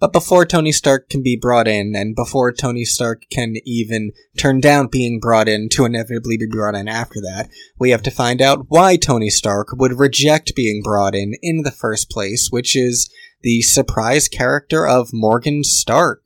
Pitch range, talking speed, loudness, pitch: 110-140 Hz, 190 wpm, -15 LUFS, 120 Hz